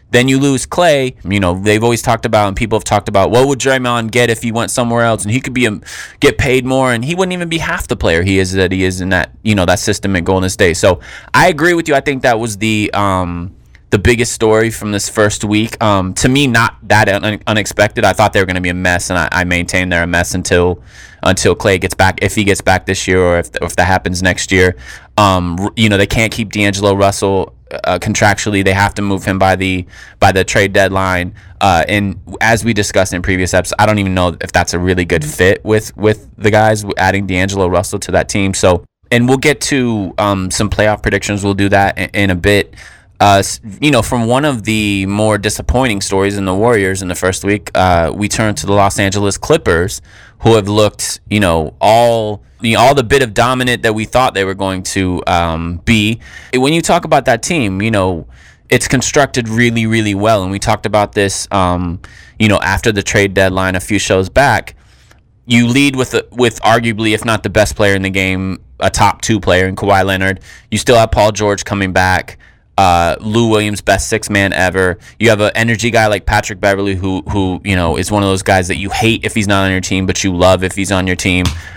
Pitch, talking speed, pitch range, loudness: 100 Hz, 235 wpm, 95-110 Hz, -12 LUFS